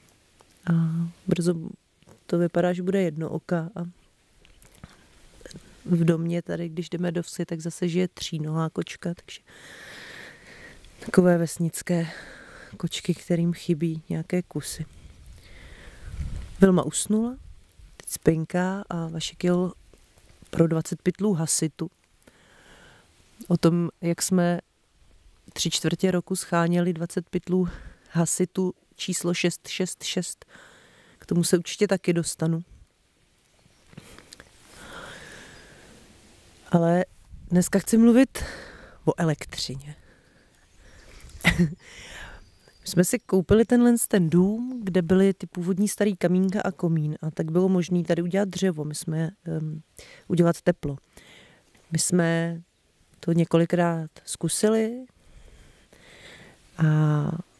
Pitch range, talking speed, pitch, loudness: 160-185 Hz, 100 wpm, 175 Hz, -25 LUFS